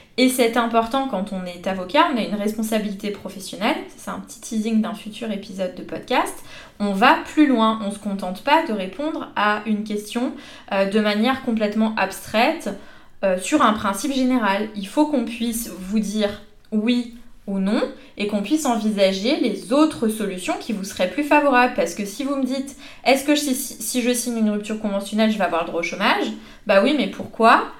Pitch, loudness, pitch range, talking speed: 220 Hz, -21 LUFS, 205-260 Hz, 200 wpm